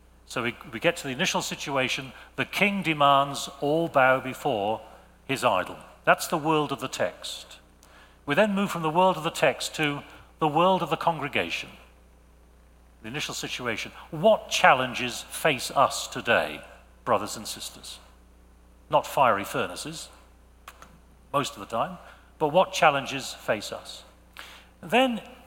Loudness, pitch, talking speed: -26 LUFS, 140 Hz, 145 wpm